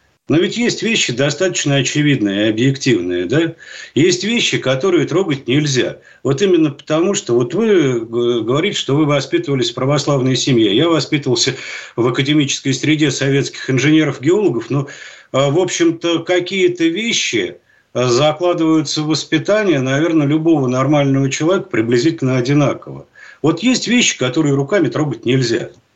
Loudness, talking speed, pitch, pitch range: -15 LUFS, 125 wpm, 150 Hz, 135-170 Hz